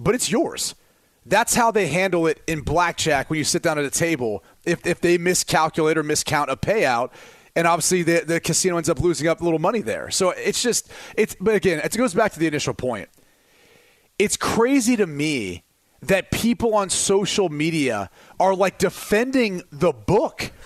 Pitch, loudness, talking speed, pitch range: 175 Hz, -21 LUFS, 190 wpm, 160-205 Hz